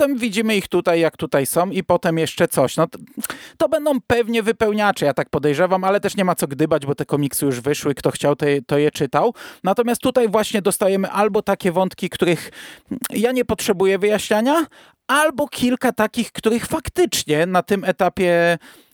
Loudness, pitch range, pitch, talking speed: -19 LUFS, 160-230 Hz, 190 Hz, 180 wpm